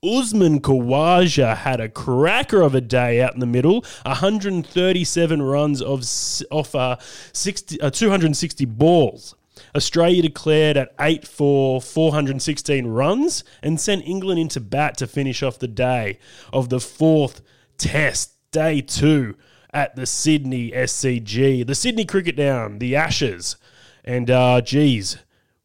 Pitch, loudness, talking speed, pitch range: 140 Hz, -19 LUFS, 130 wpm, 125-160 Hz